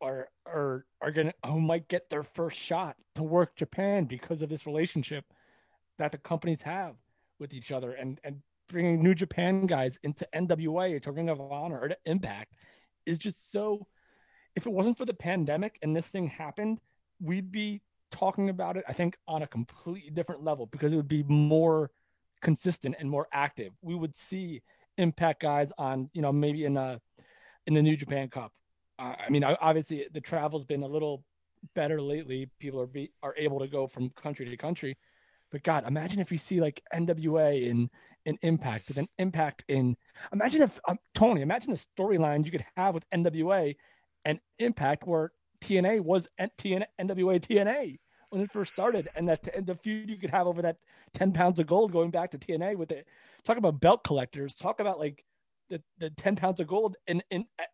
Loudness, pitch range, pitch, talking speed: -30 LUFS, 145-185 Hz, 160 Hz, 190 wpm